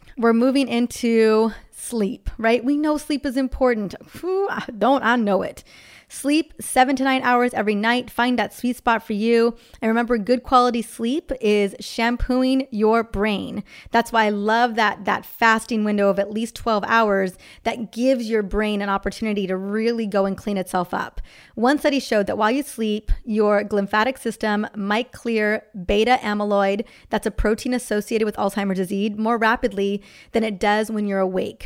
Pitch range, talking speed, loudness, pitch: 210-245 Hz, 175 wpm, -21 LUFS, 225 Hz